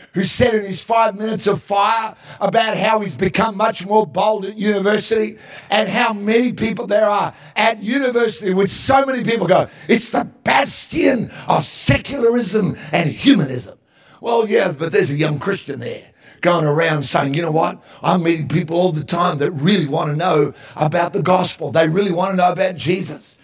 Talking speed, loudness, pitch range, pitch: 185 wpm, -17 LUFS, 170-220 Hz, 195 Hz